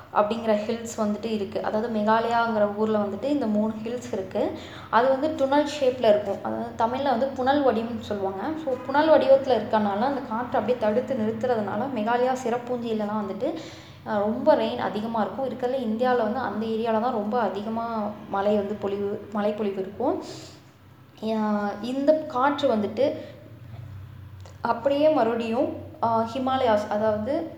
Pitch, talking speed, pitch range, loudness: 225 Hz, 130 wpm, 210-255 Hz, -25 LUFS